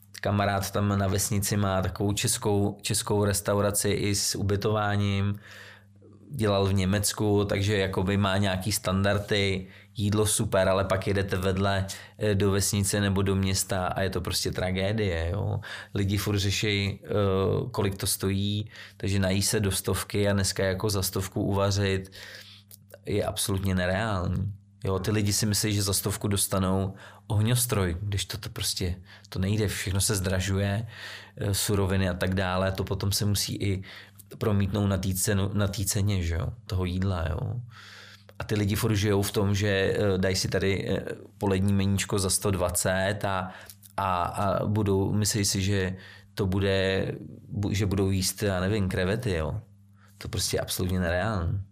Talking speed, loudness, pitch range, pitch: 150 wpm, -27 LUFS, 95-105 Hz, 100 Hz